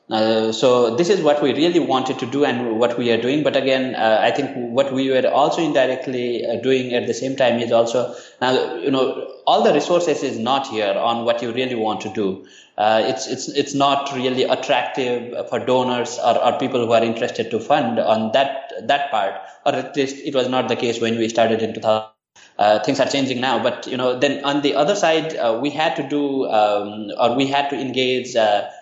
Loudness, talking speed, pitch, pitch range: -19 LUFS, 225 wpm, 130 Hz, 115-140 Hz